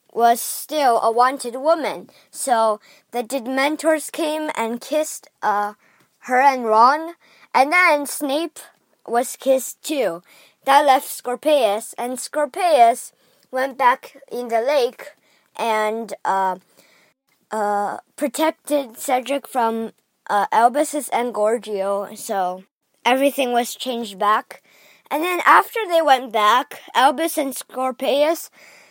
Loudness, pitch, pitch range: -20 LUFS, 260 Hz, 225-295 Hz